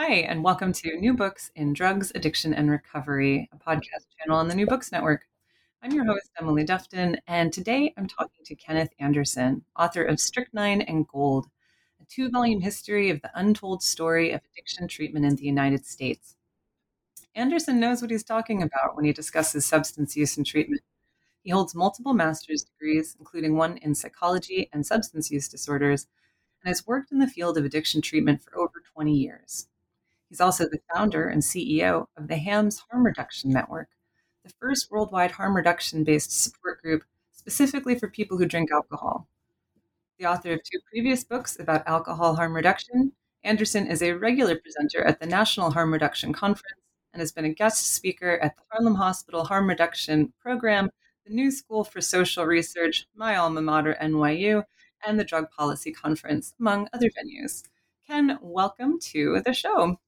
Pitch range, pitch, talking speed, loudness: 155-215 Hz, 175 Hz, 170 wpm, -25 LUFS